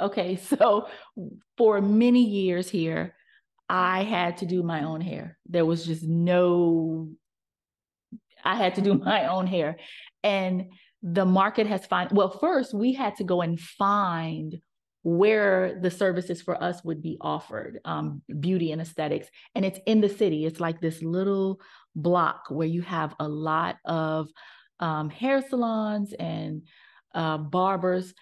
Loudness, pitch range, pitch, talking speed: -26 LUFS, 165-200 Hz, 180 Hz, 150 wpm